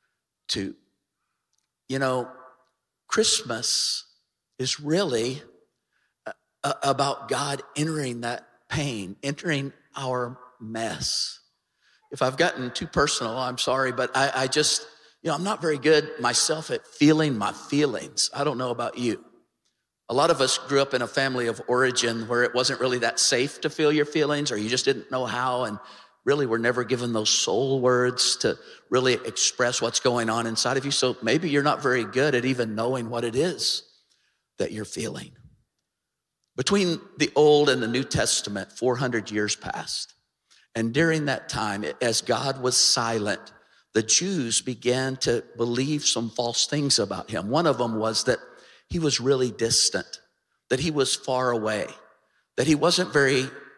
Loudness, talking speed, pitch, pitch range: -24 LUFS, 165 wpm, 130 Hz, 120-145 Hz